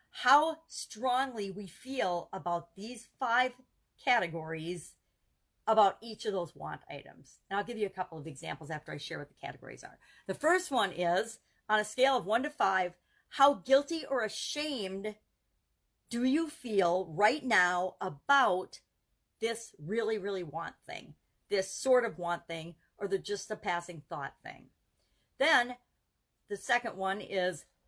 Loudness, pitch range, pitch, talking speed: -32 LUFS, 180-250 Hz, 205 Hz, 155 wpm